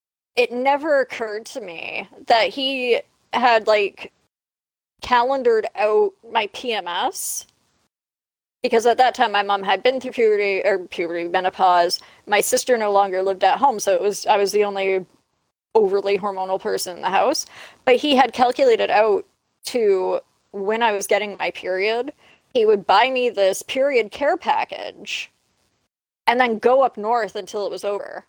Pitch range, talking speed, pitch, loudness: 200-260 Hz, 160 wpm, 225 Hz, -20 LUFS